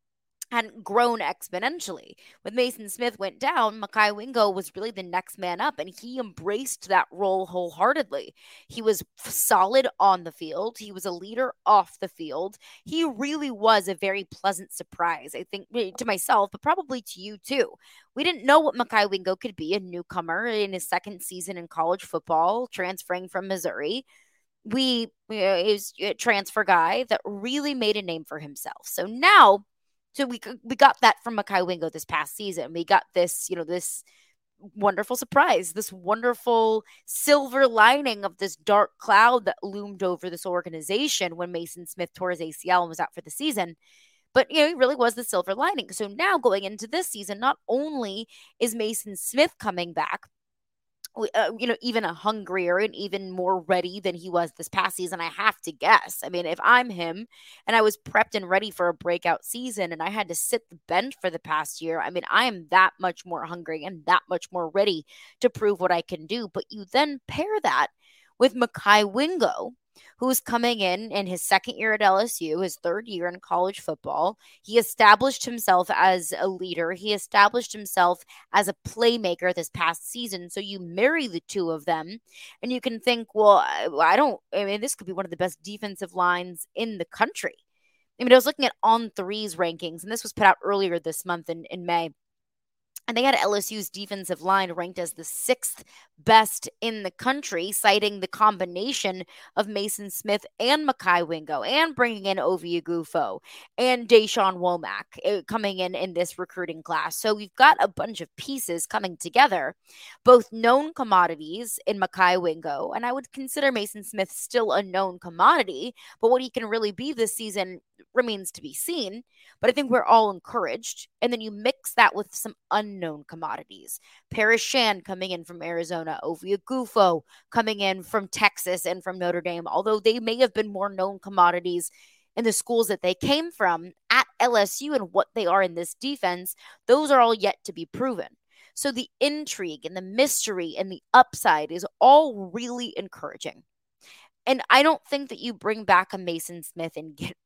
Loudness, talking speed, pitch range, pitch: -24 LUFS, 190 wpm, 180-235 Hz, 200 Hz